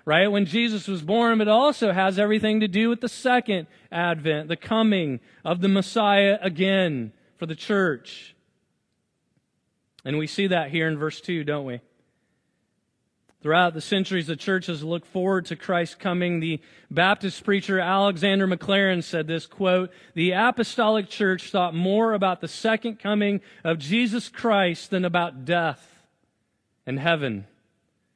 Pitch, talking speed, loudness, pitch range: 185 Hz, 150 wpm, -23 LUFS, 165-205 Hz